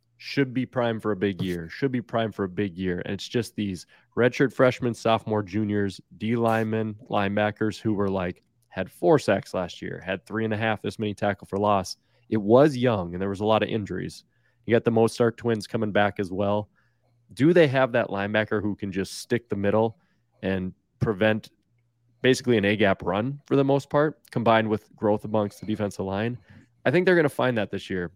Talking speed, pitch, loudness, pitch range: 210 wpm, 110 Hz, -25 LUFS, 100-120 Hz